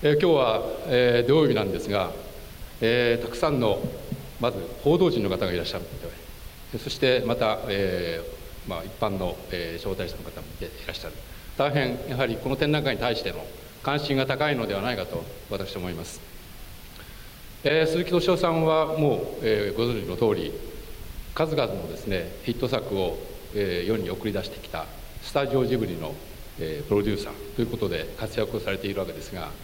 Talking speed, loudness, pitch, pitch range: 350 characters per minute, -26 LUFS, 120 Hz, 100-140 Hz